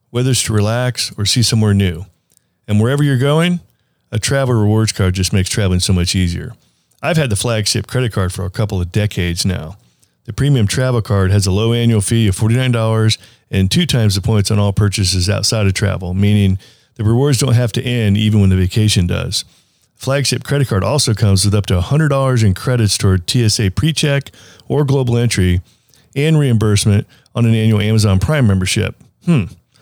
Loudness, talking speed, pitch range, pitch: -15 LUFS, 190 wpm, 100-125 Hz, 110 Hz